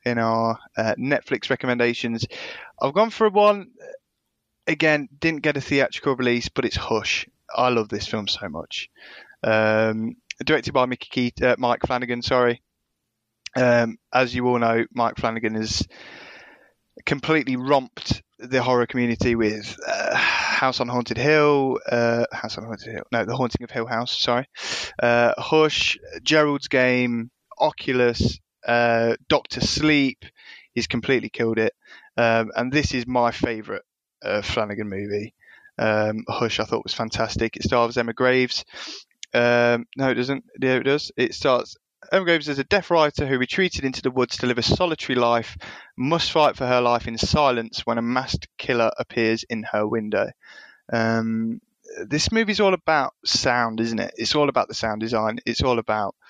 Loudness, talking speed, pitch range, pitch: -22 LUFS, 160 wpm, 115-135 Hz, 120 Hz